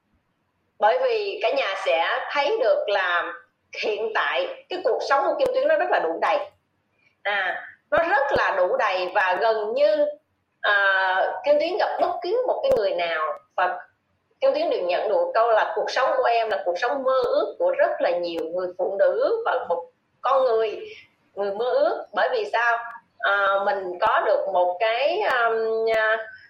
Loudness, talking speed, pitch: -23 LUFS, 185 wpm, 235 Hz